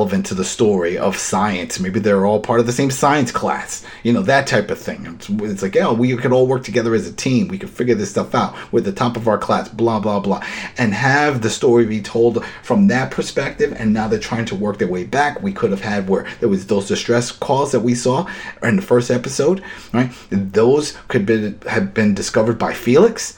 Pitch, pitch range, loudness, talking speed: 115 Hz, 105-125 Hz, -17 LUFS, 235 wpm